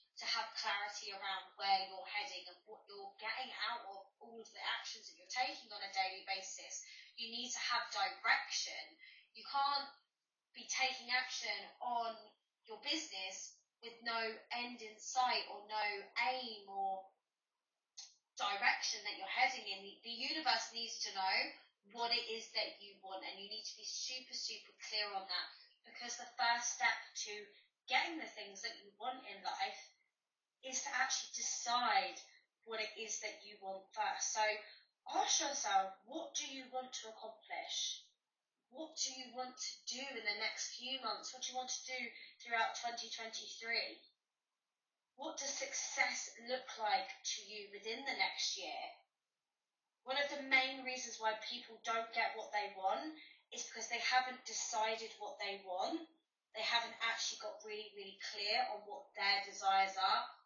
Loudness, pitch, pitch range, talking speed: -40 LUFS, 230 Hz, 205-260 Hz, 165 wpm